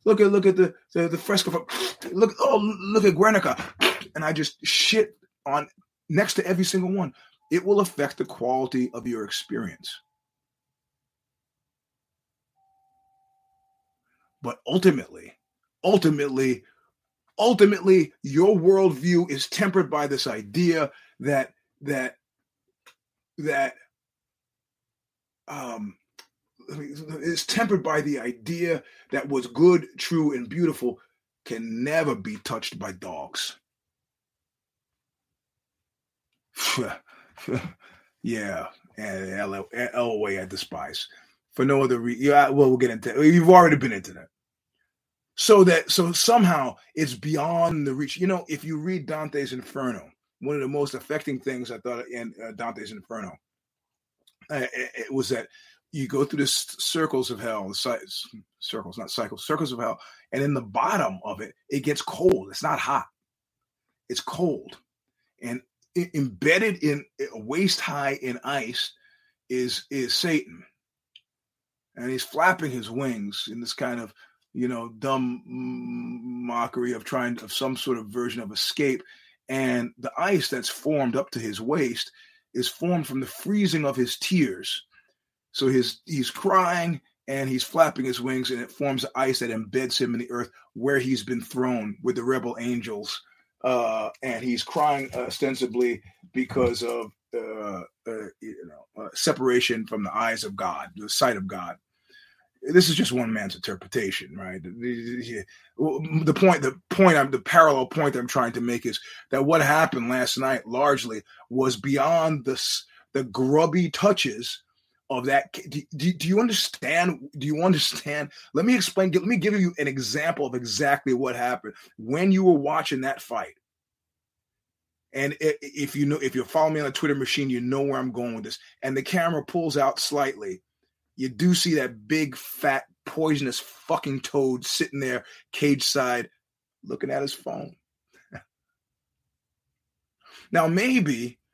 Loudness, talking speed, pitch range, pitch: -24 LUFS, 150 wpm, 125-175 Hz, 140 Hz